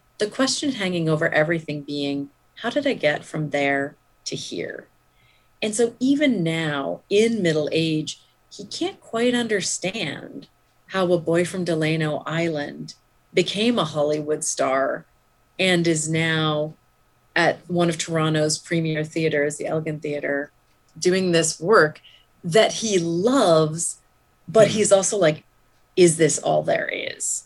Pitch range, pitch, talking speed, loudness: 150-190 Hz, 165 Hz, 135 wpm, -22 LUFS